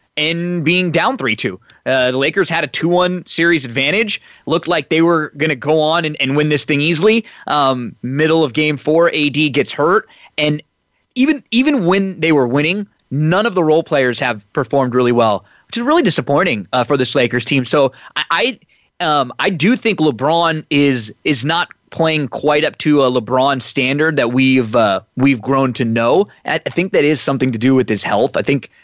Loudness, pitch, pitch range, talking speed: -15 LUFS, 150 Hz, 135-170 Hz, 200 wpm